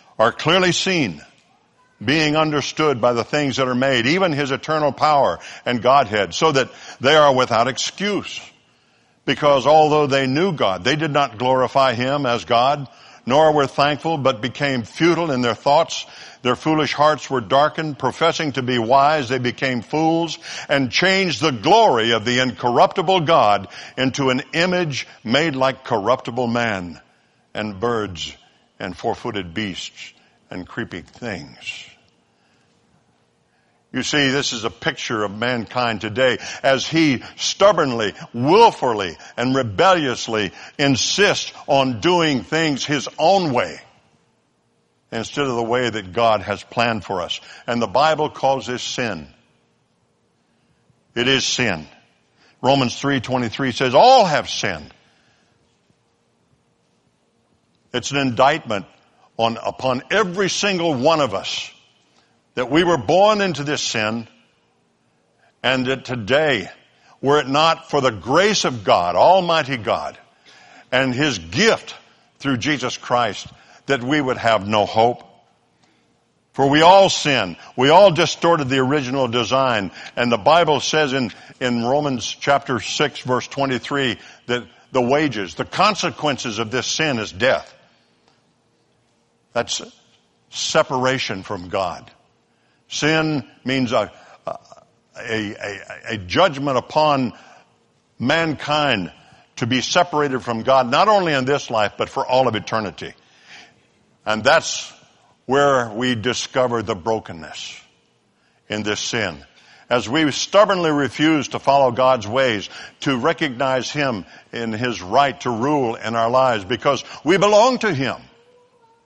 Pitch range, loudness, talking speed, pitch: 120-150 Hz, -18 LUFS, 130 wpm, 130 Hz